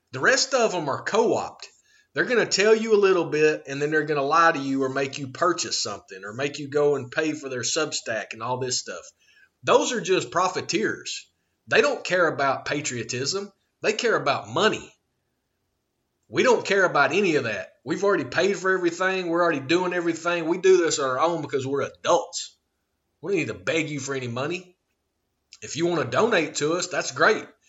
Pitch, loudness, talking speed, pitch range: 165 Hz, -23 LUFS, 210 wpm, 140-180 Hz